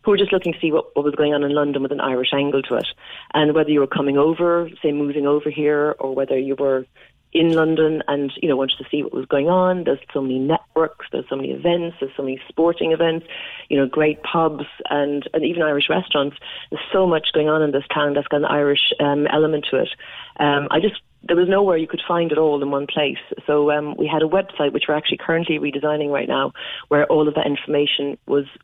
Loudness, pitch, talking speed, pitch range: -20 LUFS, 150 Hz, 245 wpm, 140-160 Hz